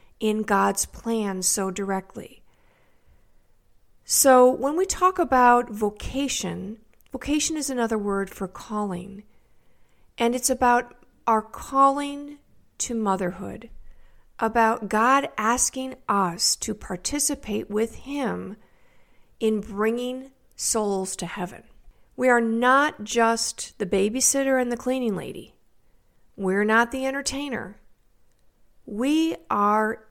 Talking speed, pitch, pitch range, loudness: 105 wpm, 230 Hz, 205-265 Hz, -23 LUFS